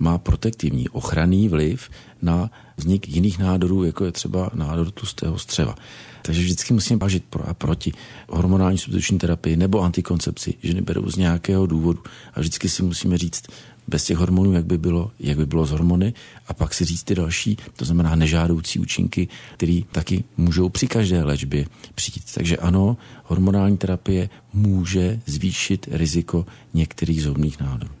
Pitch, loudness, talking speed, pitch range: 90 Hz, -22 LUFS, 160 wpm, 85-95 Hz